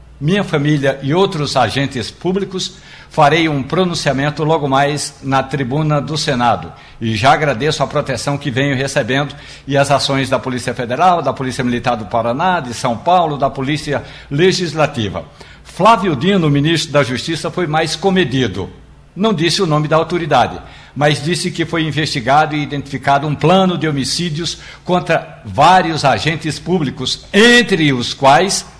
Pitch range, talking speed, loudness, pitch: 135-170 Hz, 150 wpm, -15 LUFS, 145 Hz